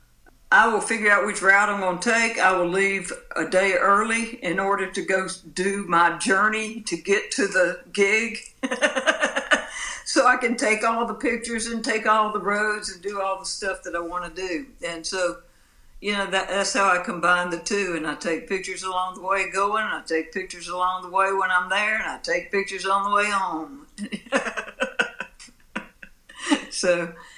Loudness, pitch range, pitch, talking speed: -23 LUFS, 185-225 Hz, 200 Hz, 195 wpm